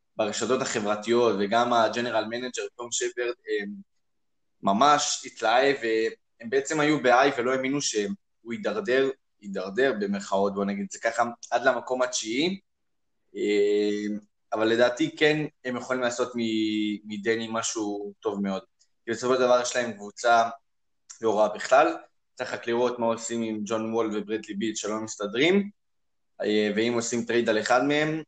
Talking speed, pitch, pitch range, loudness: 140 wpm, 115 Hz, 105-130 Hz, -26 LUFS